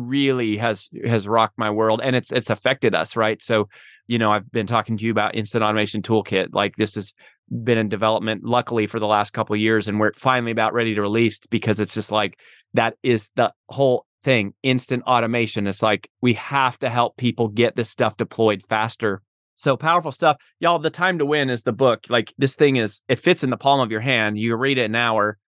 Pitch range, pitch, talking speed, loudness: 110-125 Hz, 115 Hz, 225 wpm, -21 LUFS